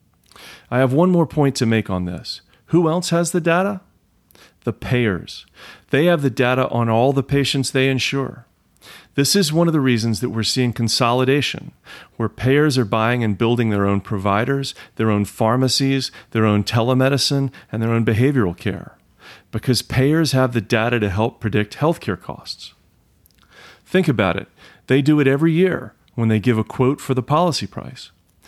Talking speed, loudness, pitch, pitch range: 175 wpm, -19 LUFS, 125 Hz, 110-140 Hz